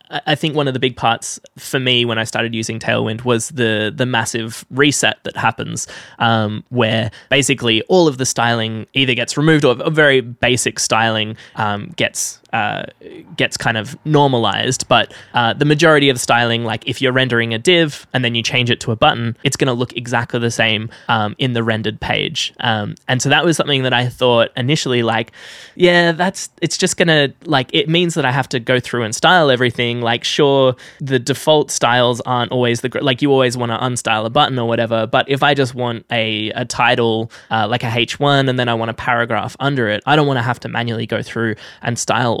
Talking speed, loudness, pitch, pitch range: 220 wpm, -16 LUFS, 125 Hz, 115-140 Hz